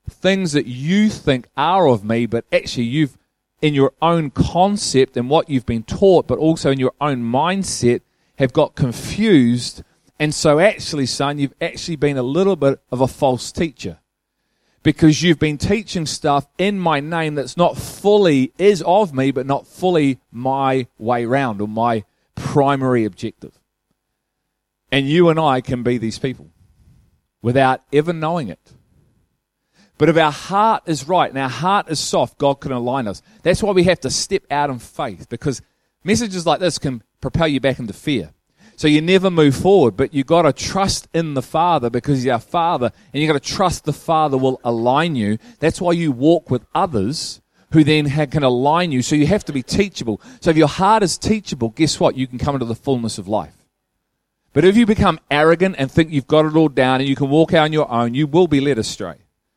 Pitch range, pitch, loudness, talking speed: 130-165 Hz, 145 Hz, -17 LUFS, 200 wpm